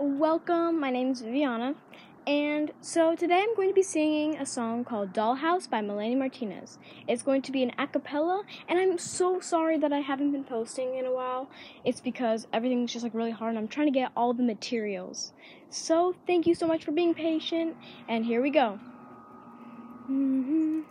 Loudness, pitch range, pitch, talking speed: -29 LUFS, 245-325 Hz, 275 Hz, 190 wpm